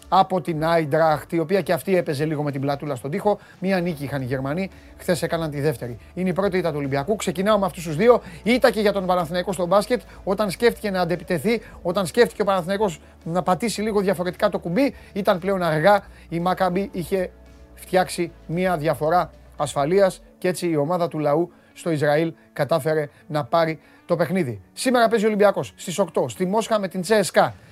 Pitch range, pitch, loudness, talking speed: 160-200 Hz, 180 Hz, -22 LUFS, 195 wpm